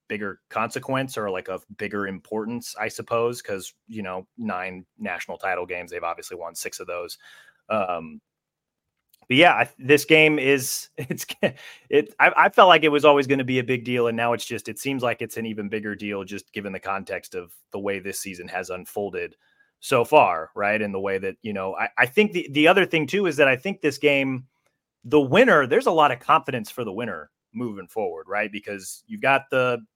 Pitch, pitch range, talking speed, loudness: 125 Hz, 105-150 Hz, 215 wpm, -22 LUFS